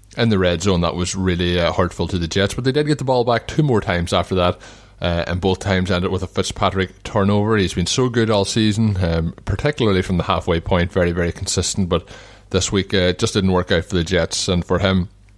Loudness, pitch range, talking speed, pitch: -19 LUFS, 90-105 Hz, 245 wpm, 95 Hz